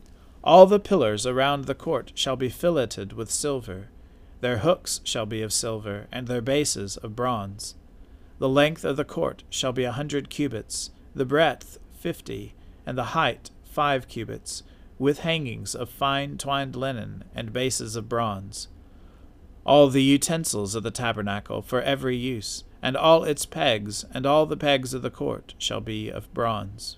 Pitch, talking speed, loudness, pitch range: 120 Hz, 165 wpm, -25 LUFS, 100-140 Hz